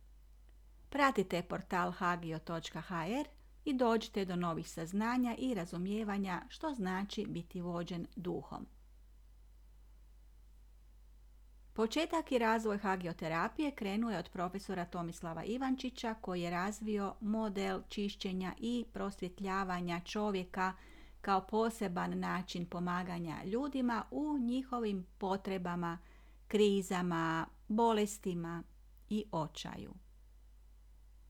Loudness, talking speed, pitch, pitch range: -38 LUFS, 85 wpm, 190 Hz, 170-220 Hz